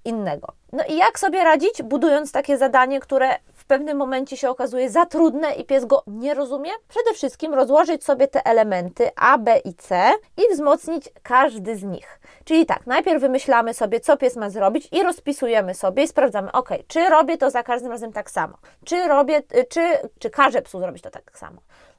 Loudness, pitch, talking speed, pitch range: -20 LUFS, 275 Hz, 190 wpm, 245-315 Hz